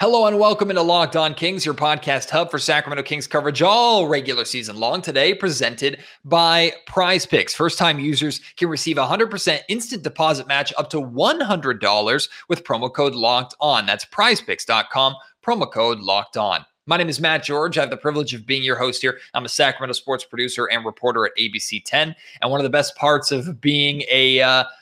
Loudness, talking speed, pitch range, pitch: -19 LUFS, 205 wpm, 130-165 Hz, 150 Hz